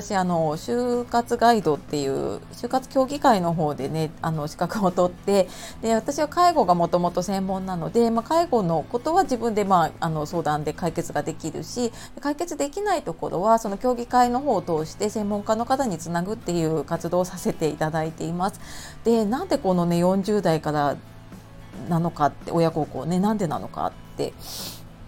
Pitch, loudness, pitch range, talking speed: 185 Hz, -24 LUFS, 160-235 Hz, 345 characters per minute